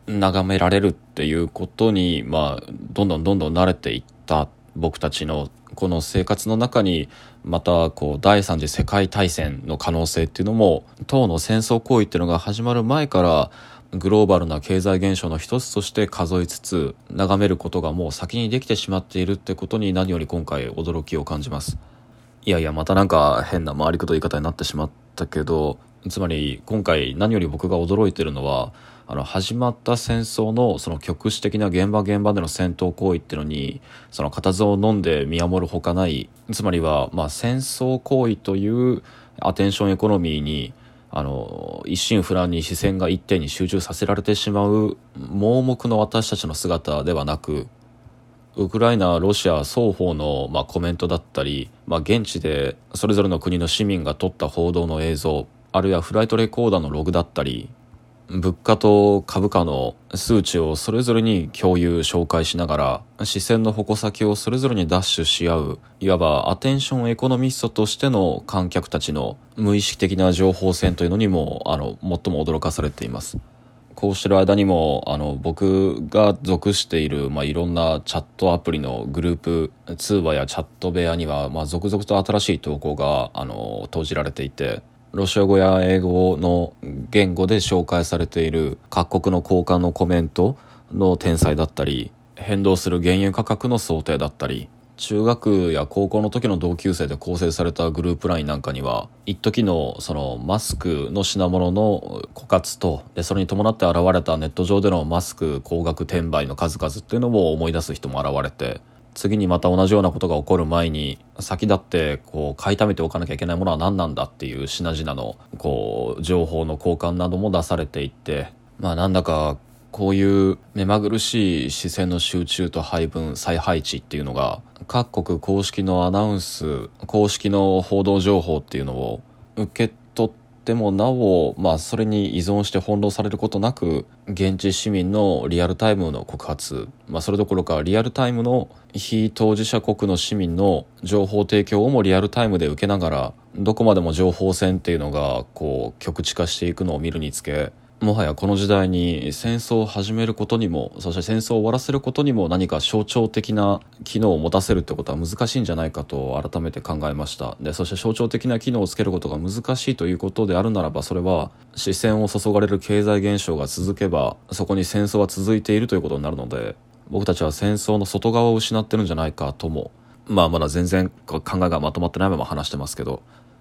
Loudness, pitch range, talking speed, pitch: -21 LUFS, 85-105 Hz, 365 characters per minute, 95 Hz